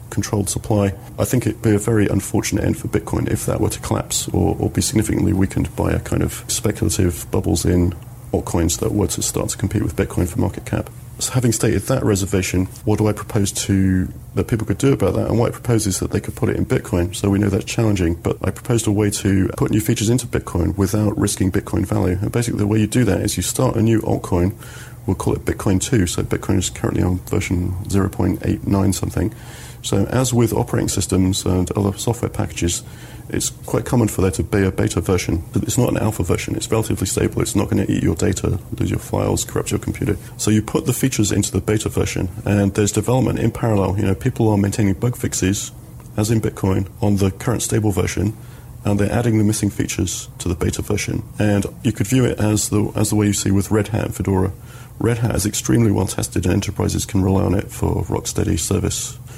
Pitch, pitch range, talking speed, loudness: 105 Hz, 100-115 Hz, 235 wpm, -19 LUFS